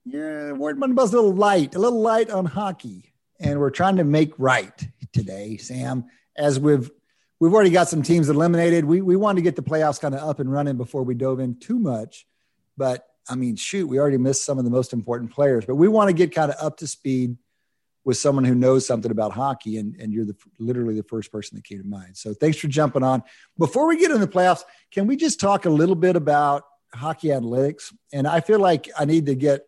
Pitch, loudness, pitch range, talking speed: 145 Hz, -21 LUFS, 125-175 Hz, 240 wpm